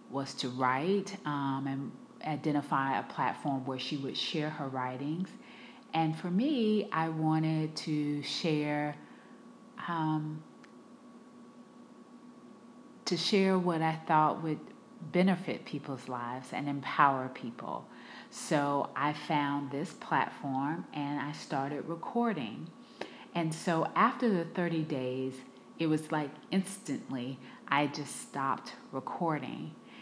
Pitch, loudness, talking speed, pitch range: 155 Hz, -33 LUFS, 115 wpm, 140-190 Hz